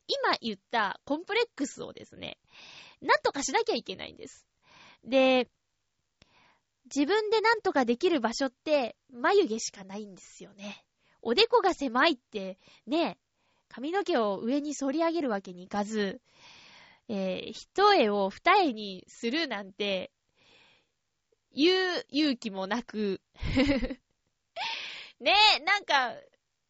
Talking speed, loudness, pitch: 240 characters per minute, -28 LUFS, 270 Hz